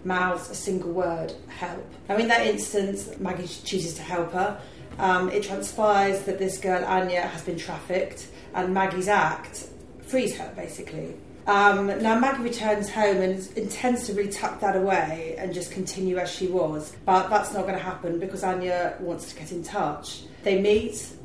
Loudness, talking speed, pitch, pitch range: -26 LUFS, 180 wpm, 185 Hz, 180-200 Hz